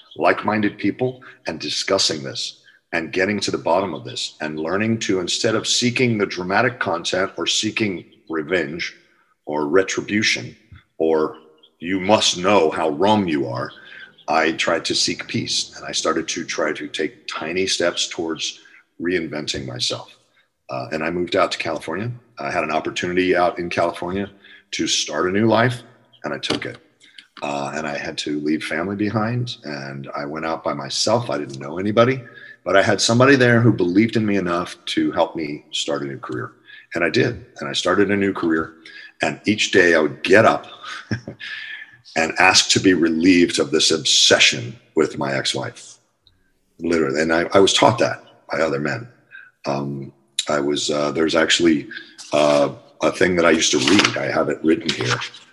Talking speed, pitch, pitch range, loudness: 180 wpm, 95 Hz, 75-115 Hz, -19 LUFS